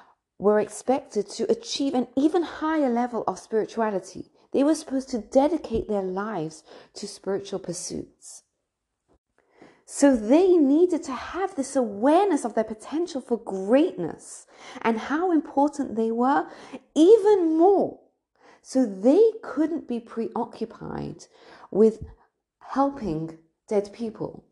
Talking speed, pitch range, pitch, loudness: 115 wpm, 215-305 Hz, 255 Hz, -24 LUFS